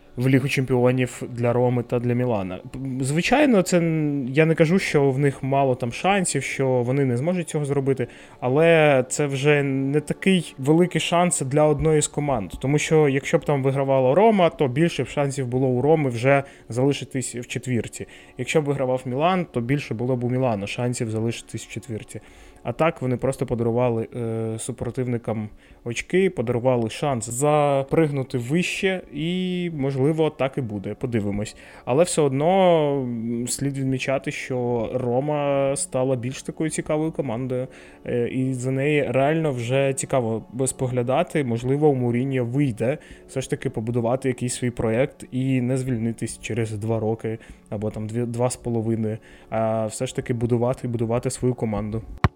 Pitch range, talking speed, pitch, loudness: 120-145 Hz, 155 wpm, 130 Hz, -23 LUFS